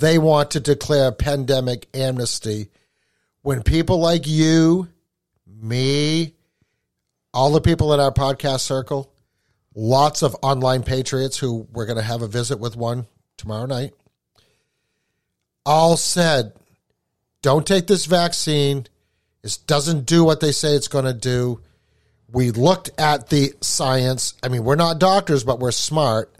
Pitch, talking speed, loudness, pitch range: 135 Hz, 145 wpm, -19 LUFS, 120-155 Hz